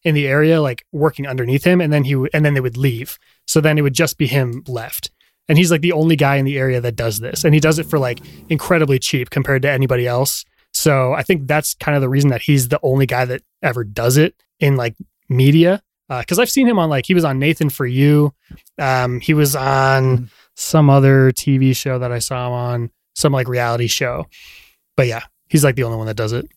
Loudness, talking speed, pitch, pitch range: -16 LUFS, 245 wpm, 140 Hz, 125-155 Hz